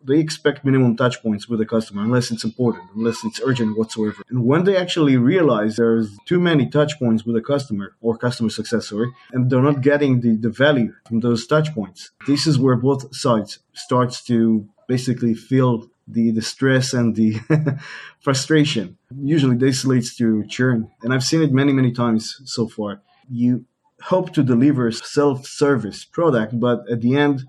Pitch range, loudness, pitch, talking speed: 115-140 Hz, -19 LUFS, 125 Hz, 180 wpm